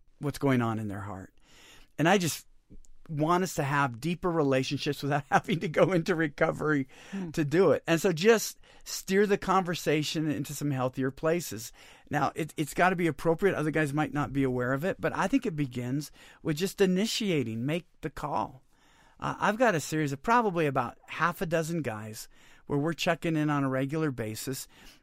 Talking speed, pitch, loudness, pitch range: 190 wpm, 155 Hz, -29 LUFS, 140-175 Hz